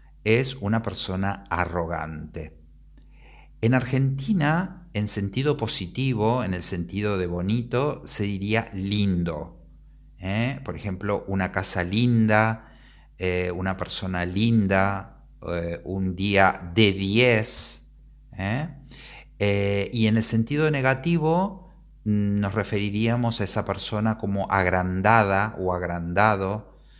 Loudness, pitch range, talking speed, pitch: -23 LUFS, 90-115 Hz, 105 wpm, 100 Hz